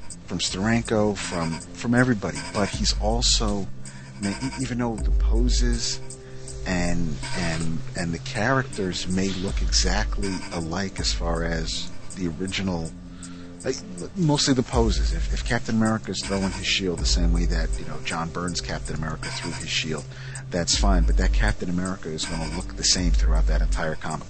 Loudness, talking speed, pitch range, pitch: -25 LUFS, 165 wpm, 85-110 Hz, 90 Hz